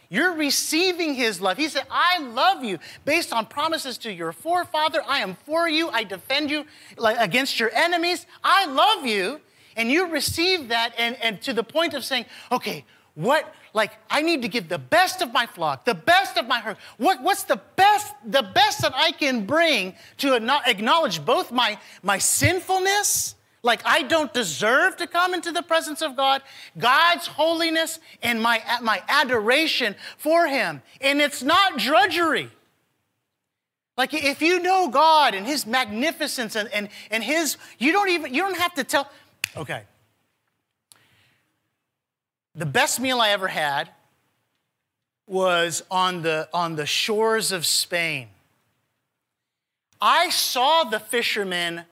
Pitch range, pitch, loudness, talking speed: 220-330 Hz, 275 Hz, -21 LUFS, 155 wpm